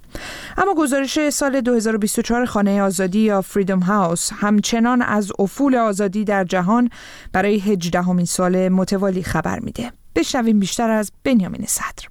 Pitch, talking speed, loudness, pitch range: 210 Hz, 130 wpm, -18 LUFS, 195-240 Hz